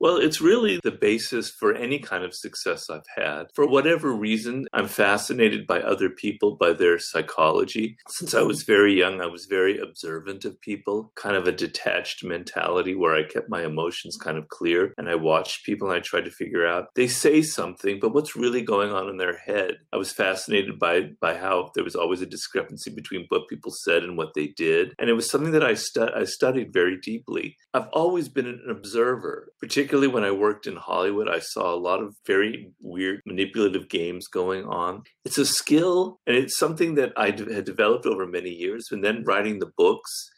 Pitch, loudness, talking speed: 145 Hz, -24 LUFS, 210 wpm